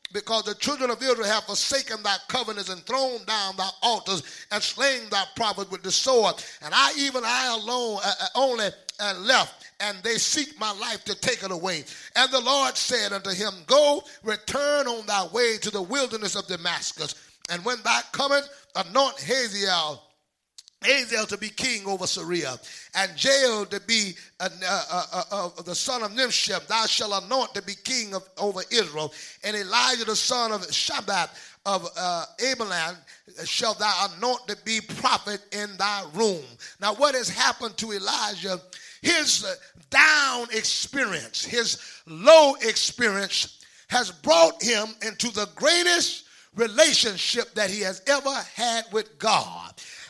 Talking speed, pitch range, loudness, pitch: 160 wpm, 195-250 Hz, -24 LUFS, 215 Hz